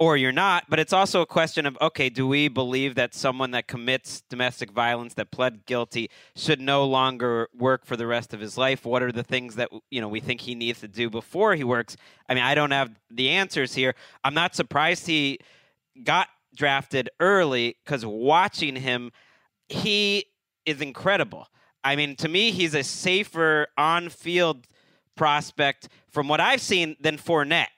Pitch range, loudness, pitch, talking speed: 125-160 Hz, -24 LUFS, 135 Hz, 180 wpm